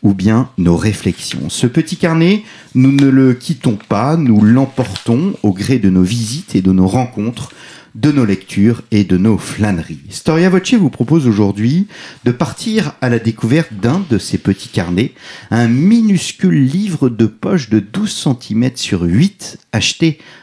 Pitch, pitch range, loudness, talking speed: 125 Hz, 105-160 Hz, -14 LUFS, 165 wpm